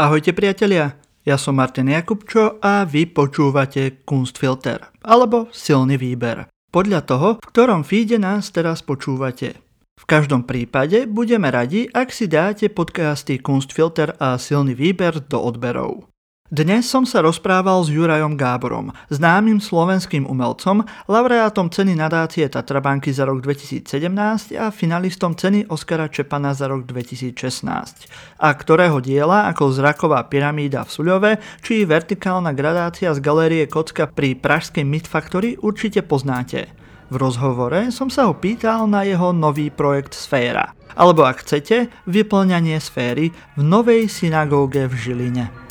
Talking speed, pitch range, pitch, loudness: 135 wpm, 140-200 Hz, 155 Hz, -18 LUFS